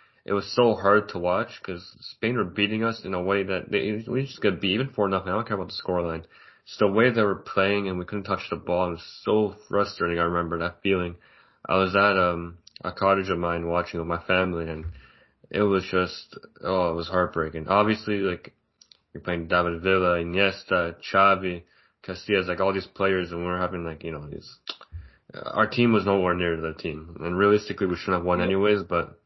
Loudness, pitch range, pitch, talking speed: -25 LUFS, 85-100 Hz, 95 Hz, 220 wpm